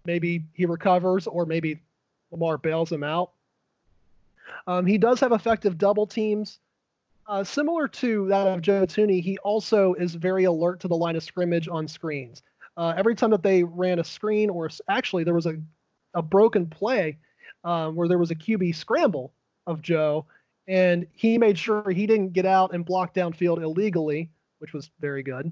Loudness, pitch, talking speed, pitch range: -24 LUFS, 175 Hz, 180 wpm, 165-200 Hz